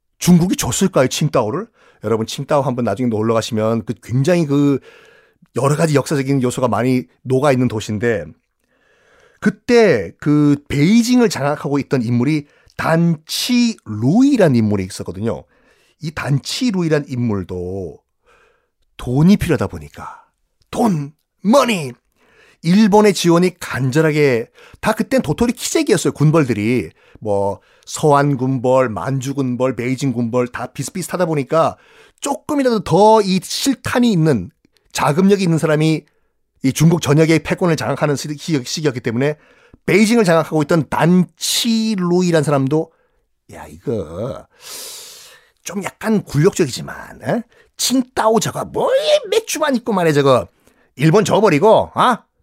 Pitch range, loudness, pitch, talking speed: 130-200 Hz, -16 LUFS, 155 Hz, 285 characters per minute